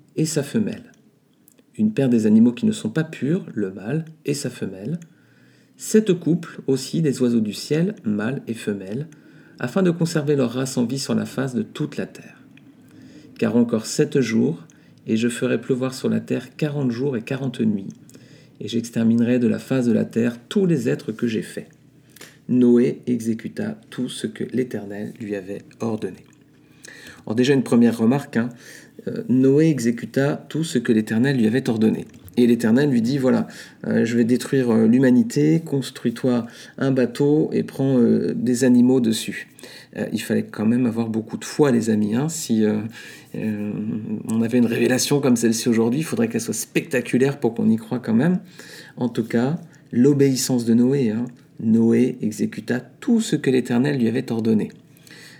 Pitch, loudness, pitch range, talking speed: 125 Hz, -21 LUFS, 115-150 Hz, 180 wpm